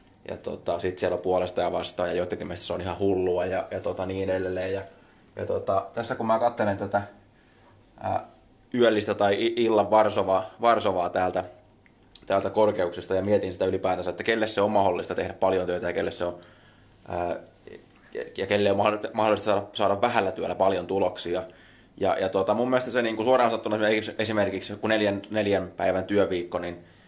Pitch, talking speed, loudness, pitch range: 100 Hz, 175 wpm, -26 LUFS, 95-110 Hz